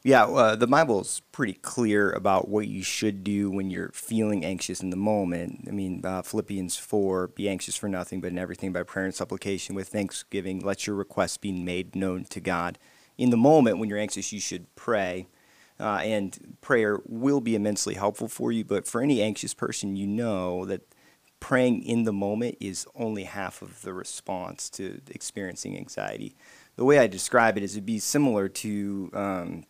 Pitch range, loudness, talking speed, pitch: 95-105 Hz, -27 LUFS, 195 wpm, 100 Hz